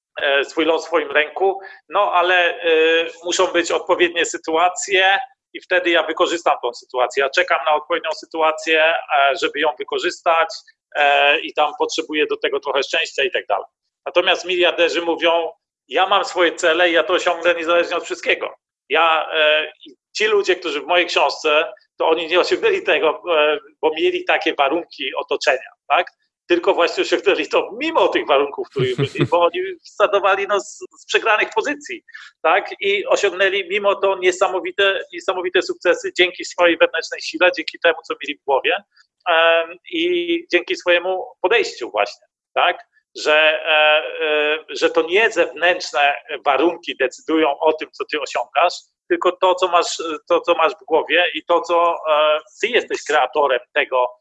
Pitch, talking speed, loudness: 180 Hz, 150 wpm, -18 LUFS